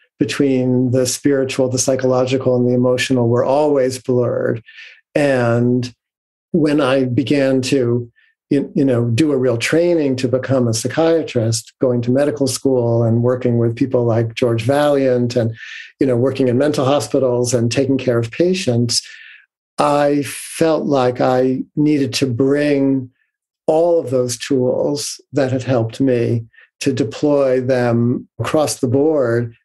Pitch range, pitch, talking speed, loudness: 125-140 Hz, 130 Hz, 140 wpm, -16 LUFS